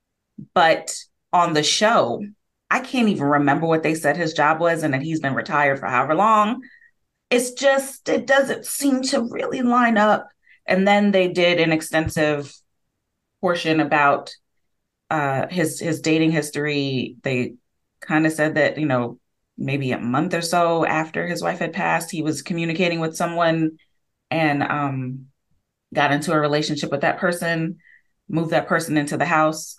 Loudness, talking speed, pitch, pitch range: -20 LUFS, 165 wpm, 160 Hz, 145-180 Hz